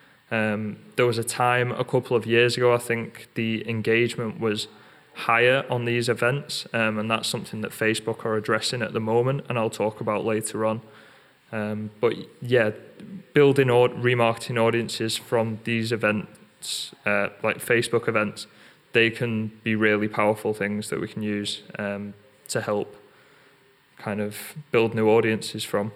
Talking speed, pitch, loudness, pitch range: 155 wpm, 115 Hz, -24 LUFS, 105-120 Hz